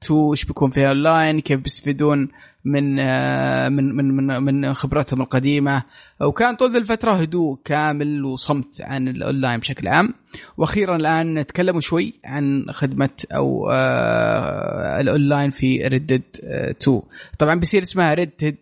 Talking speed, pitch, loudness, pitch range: 120 wpm, 145 Hz, -20 LUFS, 135-160 Hz